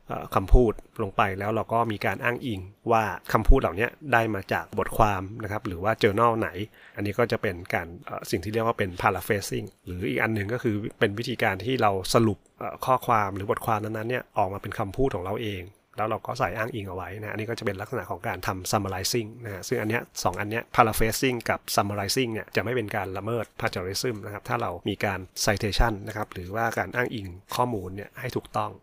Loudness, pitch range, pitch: -27 LUFS, 100-115 Hz, 110 Hz